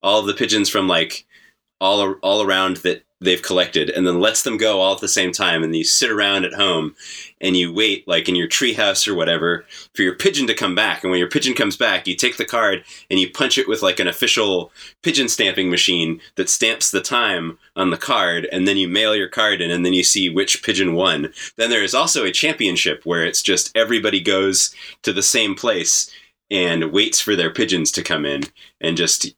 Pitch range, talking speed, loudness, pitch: 85-95 Hz, 225 wpm, -17 LUFS, 90 Hz